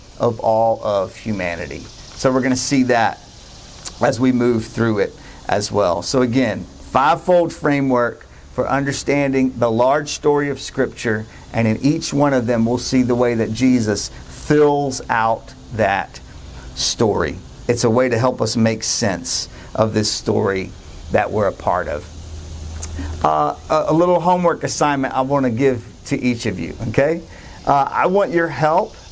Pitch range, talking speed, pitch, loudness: 100-135 Hz, 165 wpm, 120 Hz, -18 LUFS